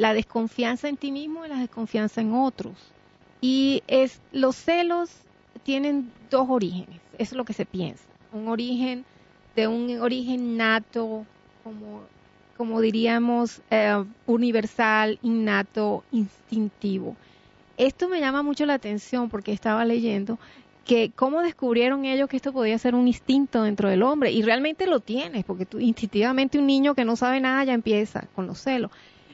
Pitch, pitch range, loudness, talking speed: 235 Hz, 220-265 Hz, -24 LUFS, 155 wpm